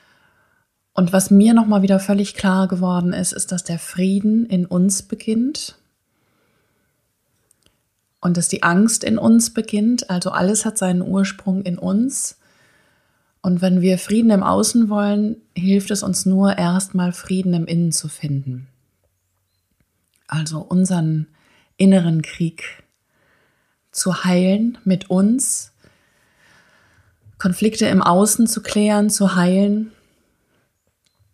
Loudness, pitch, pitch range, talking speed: -18 LUFS, 190 Hz, 175-210 Hz, 120 wpm